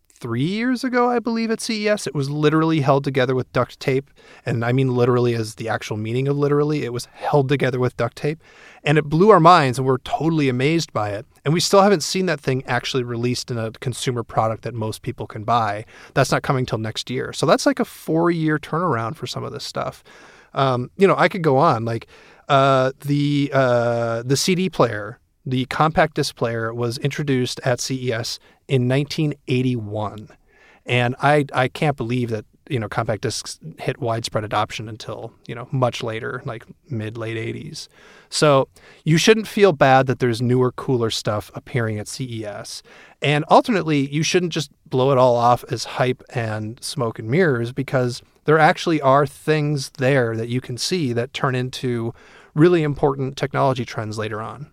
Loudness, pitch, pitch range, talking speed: -20 LUFS, 130 Hz, 120-150 Hz, 185 wpm